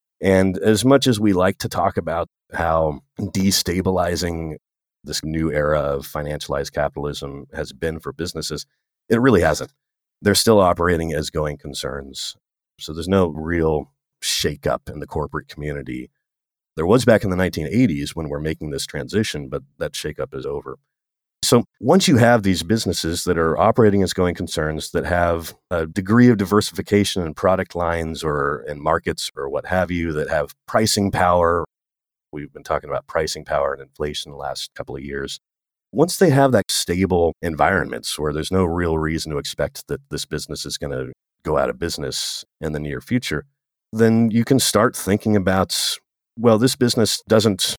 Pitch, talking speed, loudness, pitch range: 85 Hz, 170 wpm, -20 LUFS, 75-105 Hz